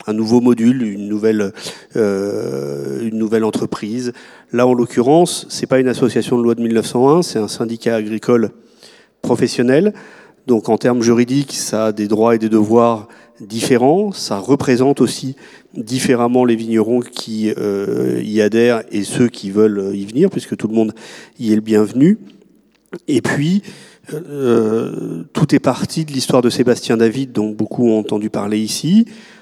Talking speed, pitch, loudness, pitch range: 160 wpm, 115 Hz, -16 LUFS, 110-130 Hz